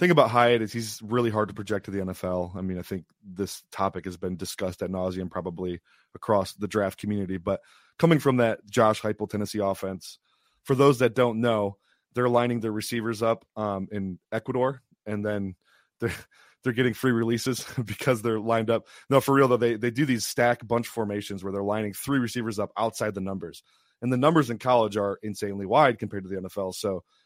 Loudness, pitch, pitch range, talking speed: -26 LUFS, 110 Hz, 100-120 Hz, 205 wpm